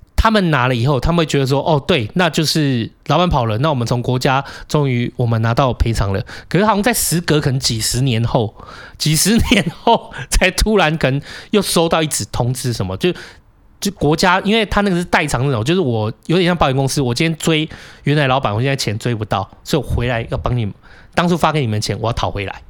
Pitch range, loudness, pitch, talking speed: 120-170 Hz, -16 LUFS, 140 Hz, 335 characters per minute